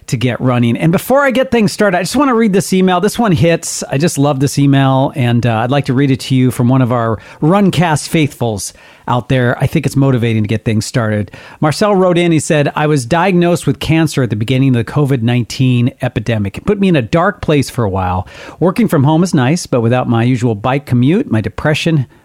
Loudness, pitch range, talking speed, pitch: -13 LUFS, 125-170 Hz, 245 wpm, 140 Hz